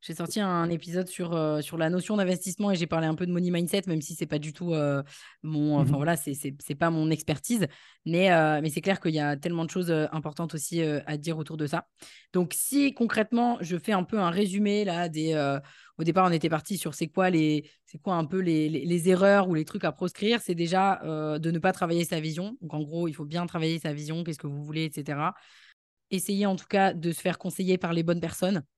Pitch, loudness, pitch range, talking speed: 170 Hz, -28 LUFS, 155-185 Hz, 255 wpm